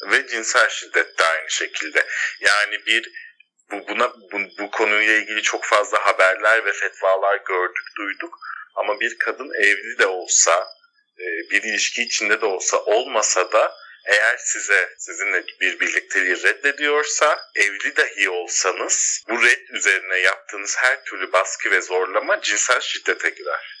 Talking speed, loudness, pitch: 140 wpm, -19 LUFS, 140 Hz